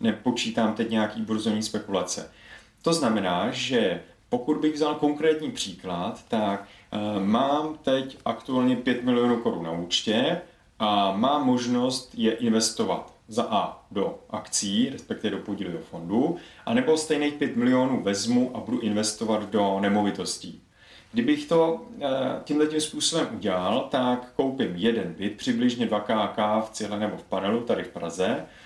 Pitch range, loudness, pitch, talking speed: 105-150 Hz, -26 LUFS, 125 Hz, 140 wpm